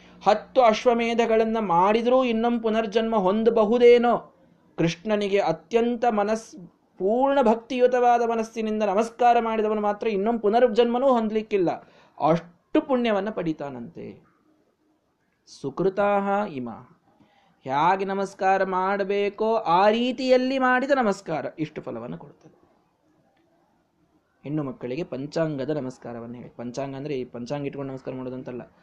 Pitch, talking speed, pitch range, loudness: 205 Hz, 90 wpm, 160-235 Hz, -23 LUFS